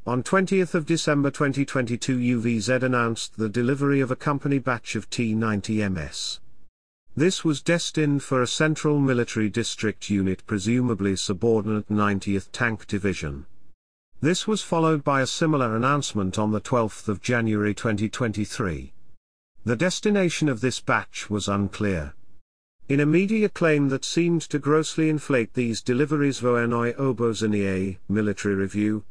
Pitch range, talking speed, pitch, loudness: 105-145 Hz, 130 wpm, 120 Hz, -24 LUFS